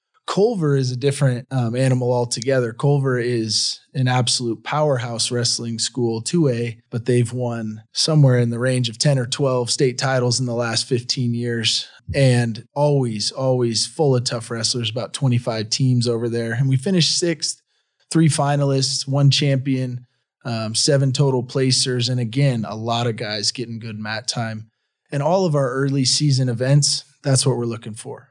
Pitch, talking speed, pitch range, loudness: 125 Hz, 165 wpm, 120-140 Hz, -20 LUFS